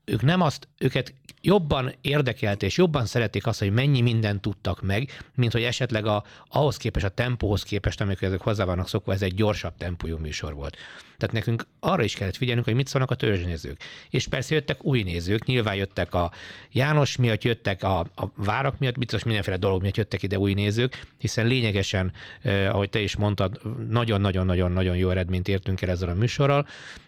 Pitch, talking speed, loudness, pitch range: 110 Hz, 185 wpm, -25 LUFS, 95-125 Hz